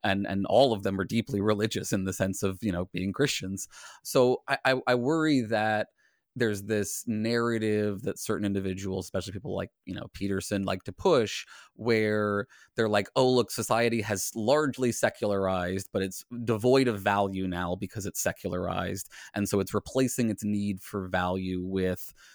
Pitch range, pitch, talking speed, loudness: 95-115 Hz, 100 Hz, 170 wpm, -29 LUFS